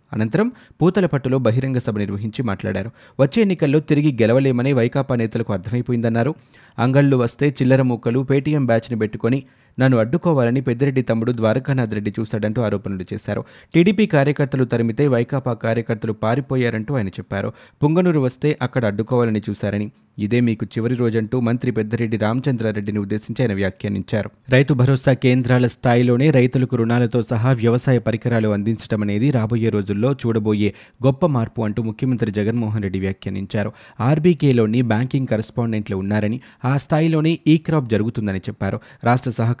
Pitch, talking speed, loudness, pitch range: 120 Hz, 125 wpm, -19 LUFS, 110-135 Hz